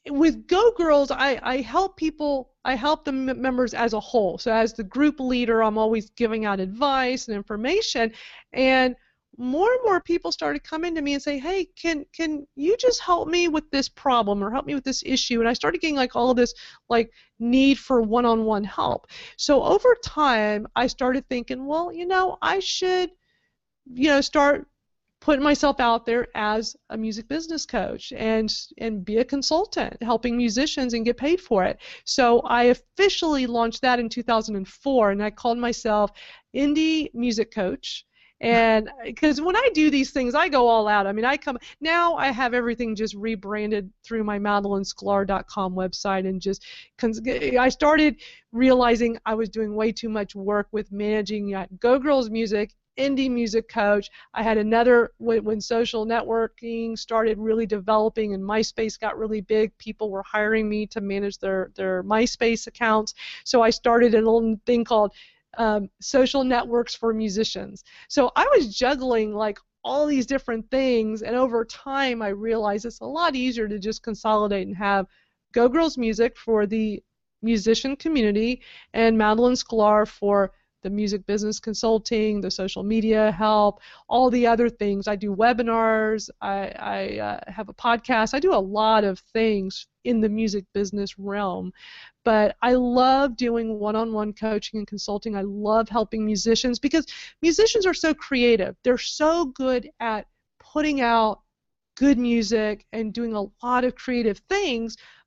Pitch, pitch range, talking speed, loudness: 230 Hz, 215-265 Hz, 170 wpm, -23 LUFS